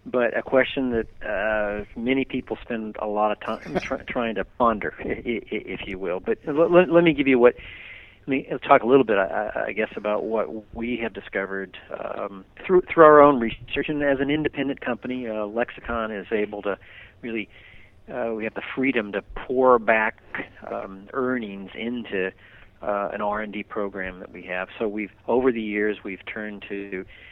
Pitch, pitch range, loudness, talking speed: 110 Hz, 105-130 Hz, -24 LUFS, 190 wpm